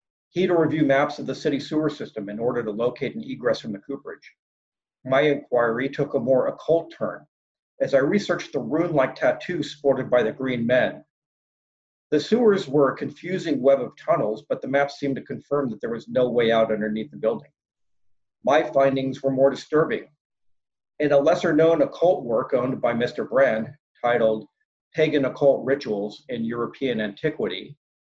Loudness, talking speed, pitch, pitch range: -23 LUFS, 175 wpm, 135 Hz, 120-150 Hz